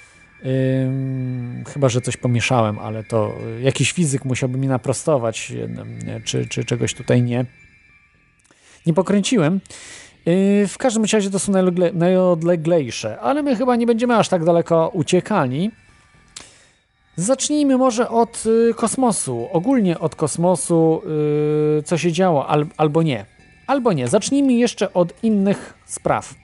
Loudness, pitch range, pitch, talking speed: -19 LUFS, 130-205 Hz, 170 Hz, 130 wpm